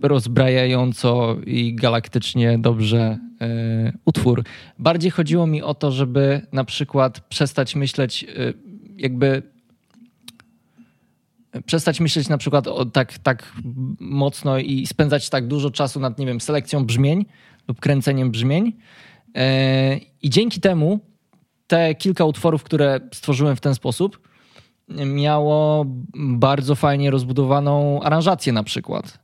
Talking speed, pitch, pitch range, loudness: 120 wpm, 140 Hz, 130-155 Hz, -20 LUFS